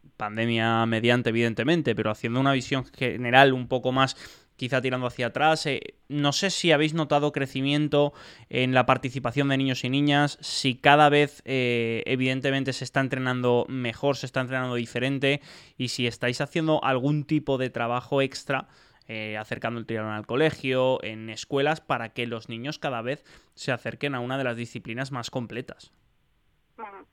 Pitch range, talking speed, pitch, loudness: 120-140 Hz, 165 wpm, 130 Hz, -25 LUFS